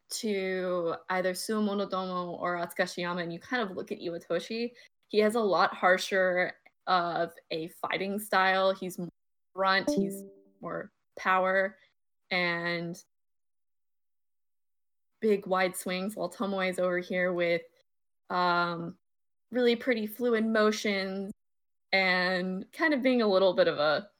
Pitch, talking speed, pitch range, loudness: 185 Hz, 125 wpm, 175-205 Hz, -29 LUFS